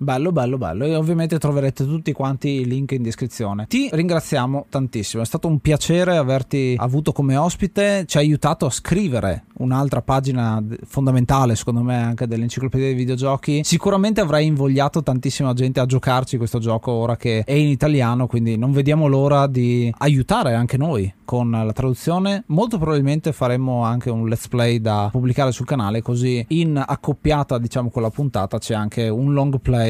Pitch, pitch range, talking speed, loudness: 130 Hz, 120-145 Hz, 170 wpm, -19 LUFS